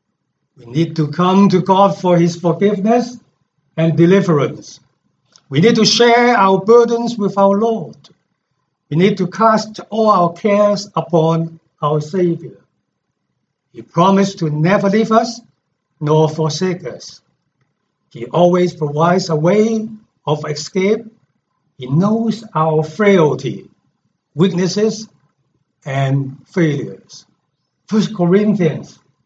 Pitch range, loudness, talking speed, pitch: 155-210 Hz, -14 LUFS, 115 wpm, 180 Hz